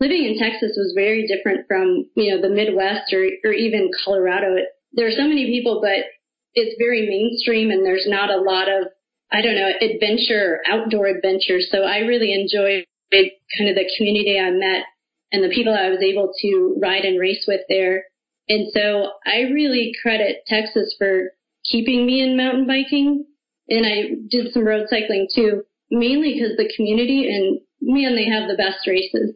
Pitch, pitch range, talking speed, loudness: 215 Hz, 195-240 Hz, 180 wpm, -19 LUFS